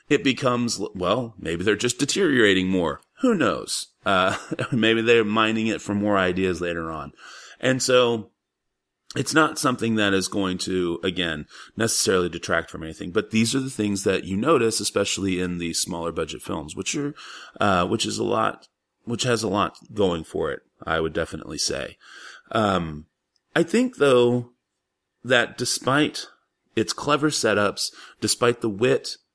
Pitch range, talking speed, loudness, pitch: 90-120 Hz, 160 wpm, -23 LUFS, 105 Hz